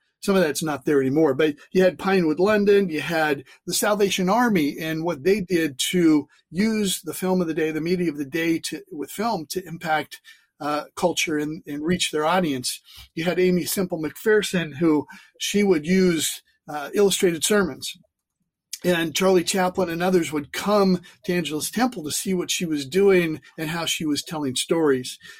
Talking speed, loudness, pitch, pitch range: 185 wpm, -22 LUFS, 175 Hz, 155-190 Hz